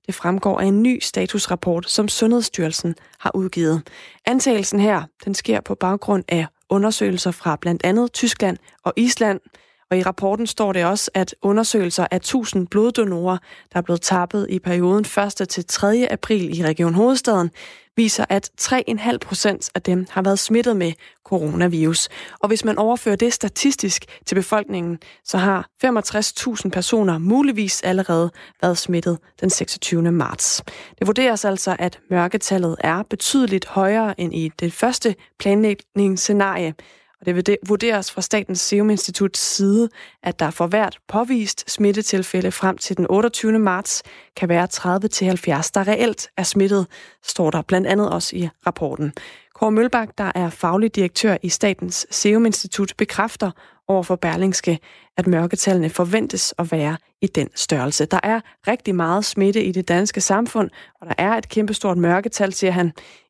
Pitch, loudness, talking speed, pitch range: 195 Hz, -20 LUFS, 155 wpm, 180-215 Hz